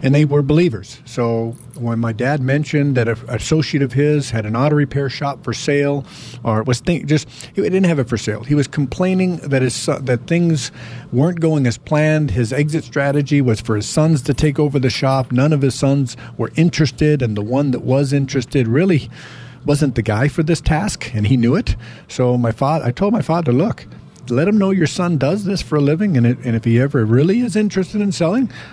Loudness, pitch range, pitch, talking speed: -17 LUFS, 120-155 Hz, 140 Hz, 225 wpm